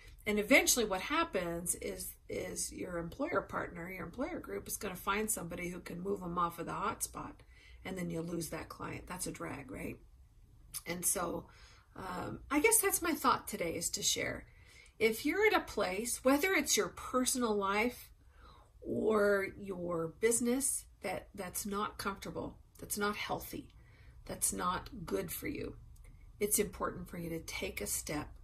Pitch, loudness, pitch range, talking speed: 200 Hz, -35 LUFS, 170-235 Hz, 175 wpm